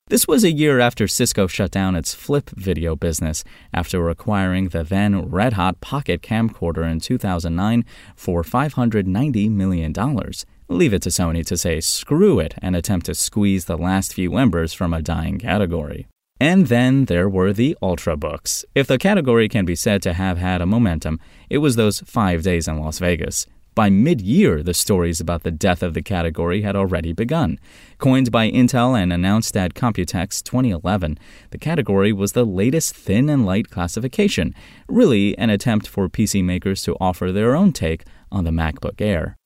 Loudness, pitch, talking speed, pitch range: -19 LUFS, 95 Hz, 175 wpm, 85-115 Hz